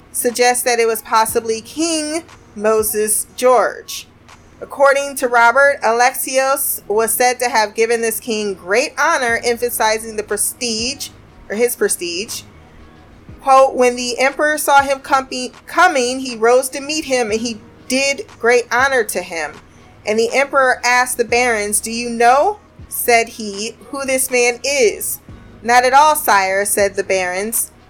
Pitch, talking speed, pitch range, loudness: 245 Hz, 145 wpm, 225-275 Hz, -15 LUFS